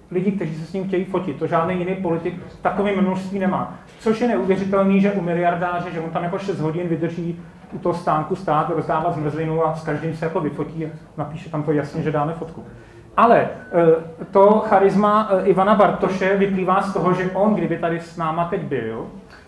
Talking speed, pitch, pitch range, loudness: 195 wpm, 175 Hz, 165-190 Hz, -20 LUFS